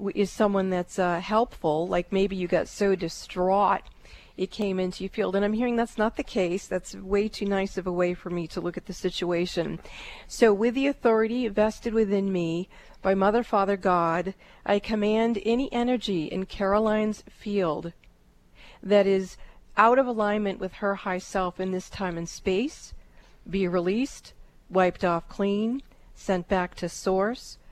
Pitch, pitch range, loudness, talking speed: 195 Hz, 180-215 Hz, -26 LUFS, 170 wpm